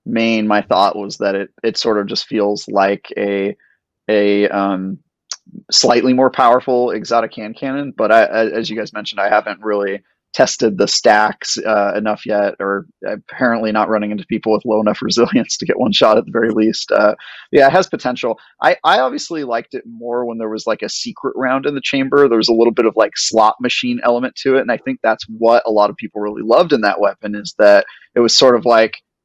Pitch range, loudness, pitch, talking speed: 105-120 Hz, -15 LUFS, 110 Hz, 220 wpm